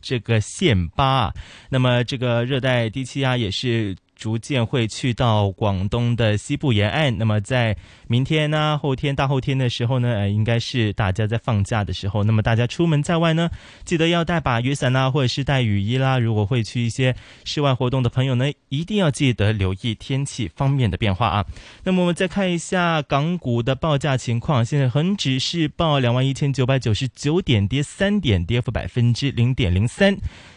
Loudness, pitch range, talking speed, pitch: -21 LUFS, 115-145 Hz, 300 characters per minute, 125 Hz